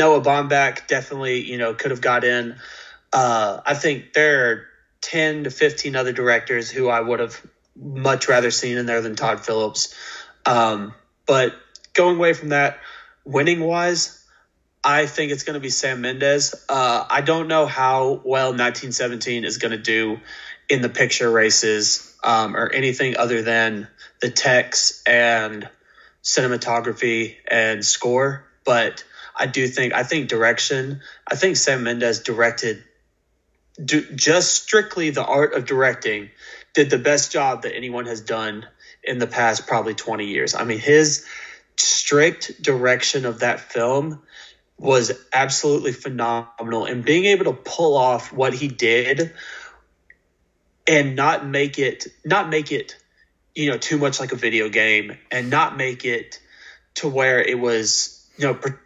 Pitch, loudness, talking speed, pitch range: 125 Hz, -19 LUFS, 155 wpm, 115-145 Hz